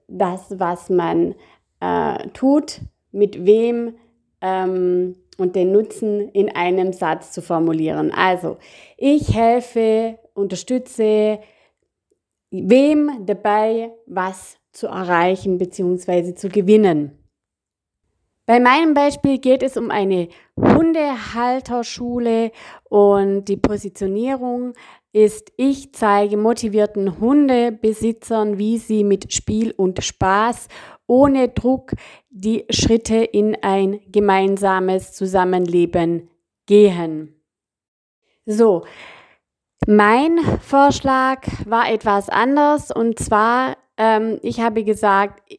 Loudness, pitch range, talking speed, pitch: -18 LUFS, 185-235 Hz, 95 wpm, 210 Hz